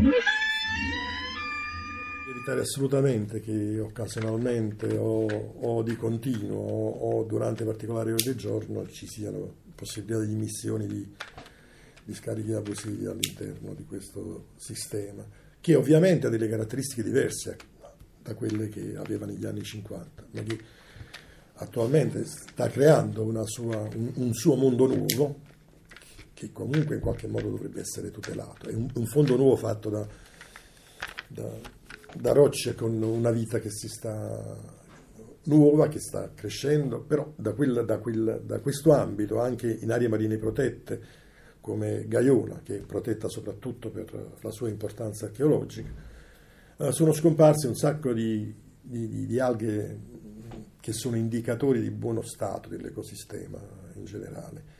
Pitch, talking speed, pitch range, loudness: 115 Hz, 135 wpm, 110-135 Hz, -28 LUFS